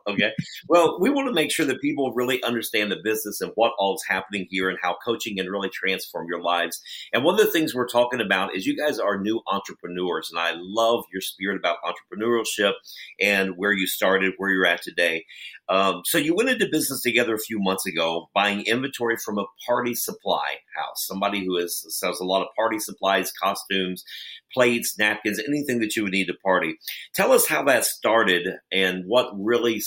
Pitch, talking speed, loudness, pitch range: 100 Hz, 205 wpm, -23 LUFS, 95-120 Hz